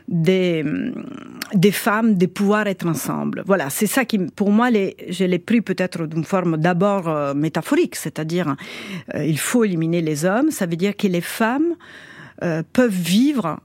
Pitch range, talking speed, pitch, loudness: 165-220 Hz, 170 wpm, 190 Hz, -20 LUFS